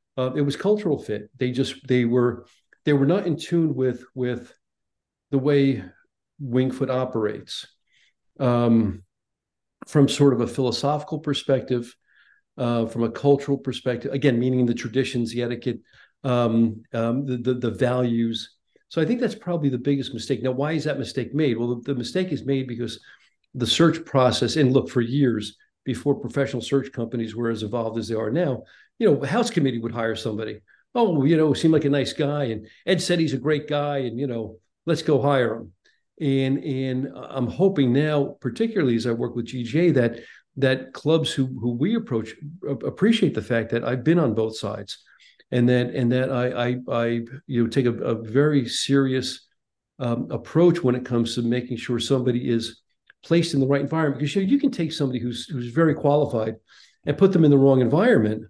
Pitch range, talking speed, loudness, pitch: 120-145 Hz, 190 wpm, -23 LUFS, 130 Hz